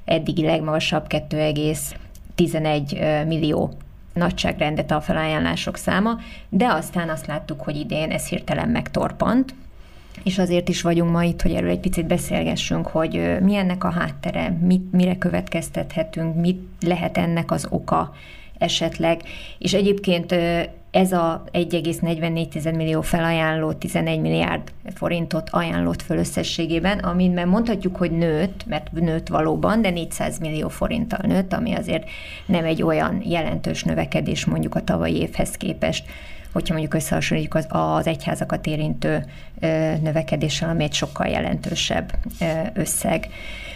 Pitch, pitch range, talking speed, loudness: 165 Hz, 155-180 Hz, 125 wpm, -22 LUFS